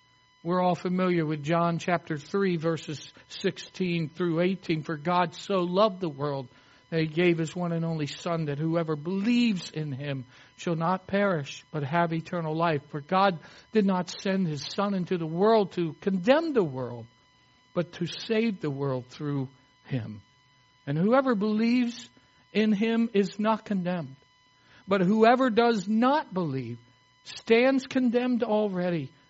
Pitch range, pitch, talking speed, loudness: 145-200 Hz, 170 Hz, 150 wpm, -27 LUFS